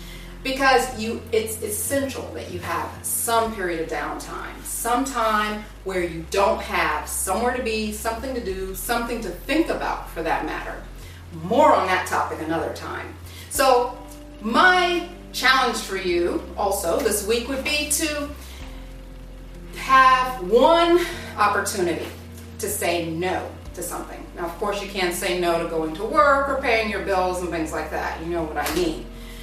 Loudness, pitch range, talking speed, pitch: -22 LUFS, 170-255 Hz, 160 wpm, 205 Hz